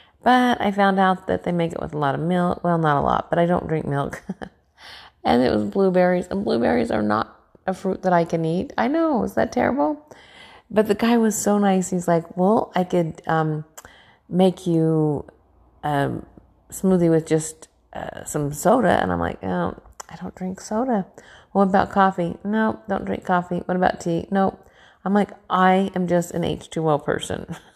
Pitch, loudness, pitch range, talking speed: 180 Hz, -21 LUFS, 160-195 Hz, 195 wpm